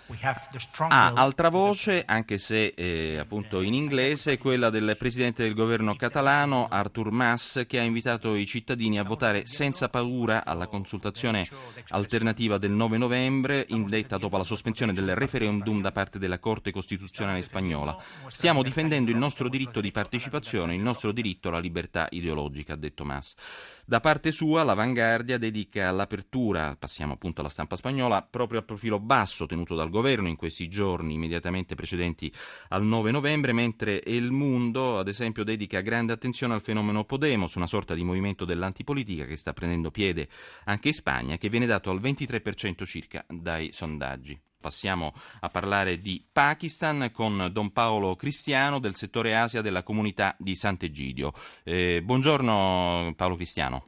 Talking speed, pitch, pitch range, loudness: 155 wpm, 105 Hz, 90-125 Hz, -27 LUFS